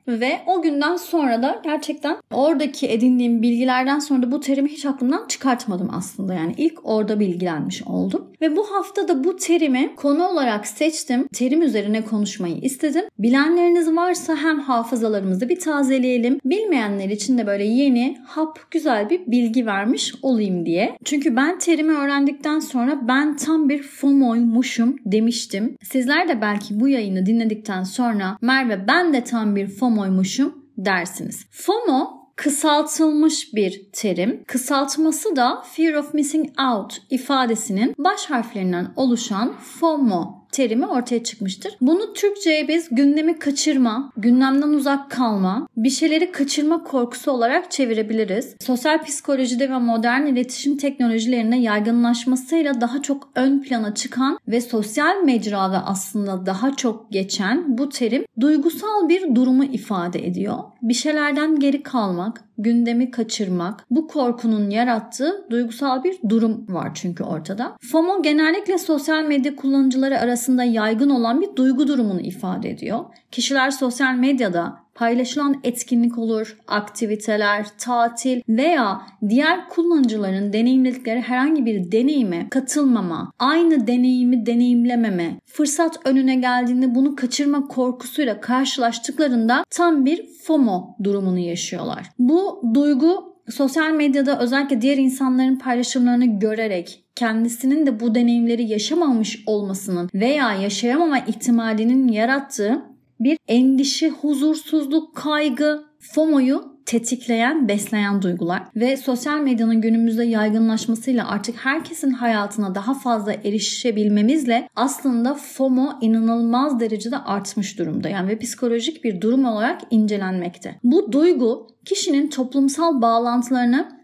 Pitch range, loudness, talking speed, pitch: 225-290 Hz, -20 LUFS, 120 wpm, 250 Hz